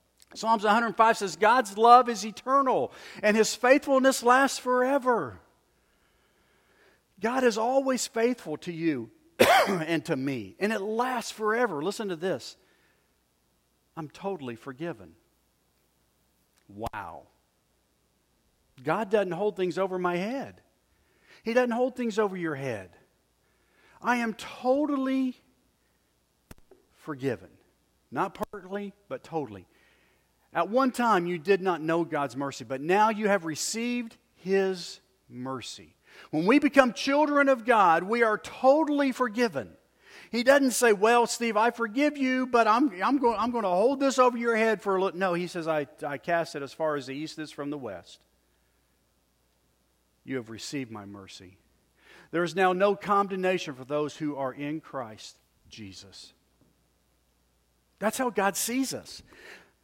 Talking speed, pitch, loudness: 140 wpm, 195 Hz, -26 LUFS